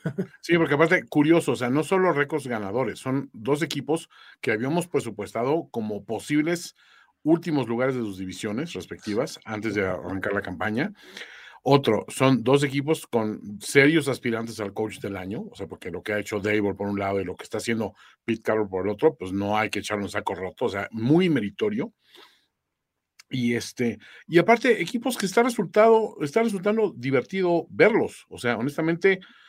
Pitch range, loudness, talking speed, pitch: 110-170 Hz, -25 LUFS, 180 wpm, 135 Hz